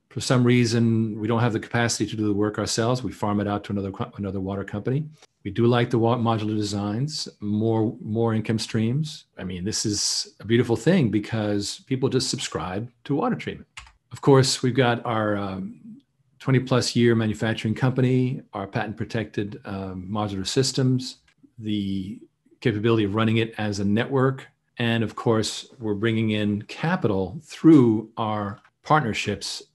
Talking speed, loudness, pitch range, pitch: 160 wpm, -24 LUFS, 105-125 Hz, 115 Hz